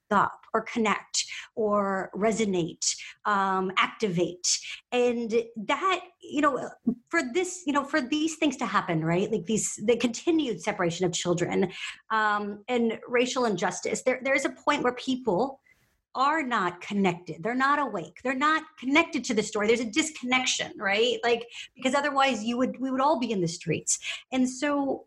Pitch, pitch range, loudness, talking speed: 240 Hz, 205-280 Hz, -27 LUFS, 165 wpm